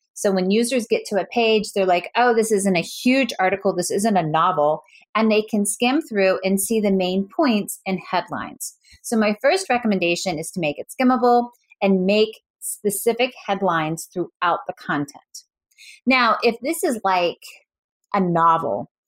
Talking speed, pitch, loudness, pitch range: 170 wpm, 205 Hz, -20 LUFS, 185-235 Hz